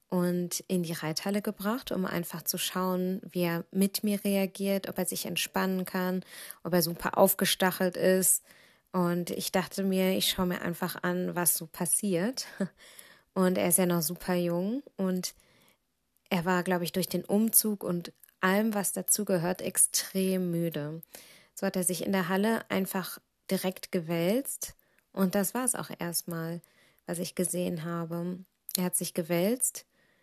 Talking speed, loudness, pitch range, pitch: 165 wpm, -29 LUFS, 175-195 Hz, 185 Hz